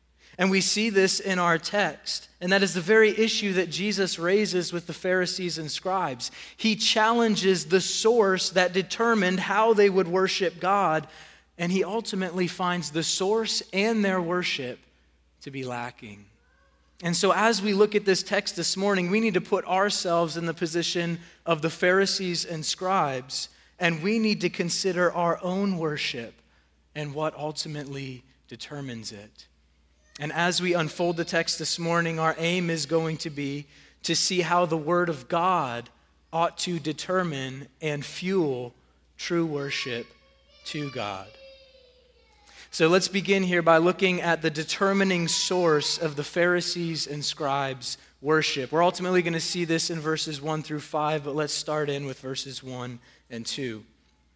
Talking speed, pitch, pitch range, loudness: 160 wpm, 170 Hz, 150-190 Hz, -25 LUFS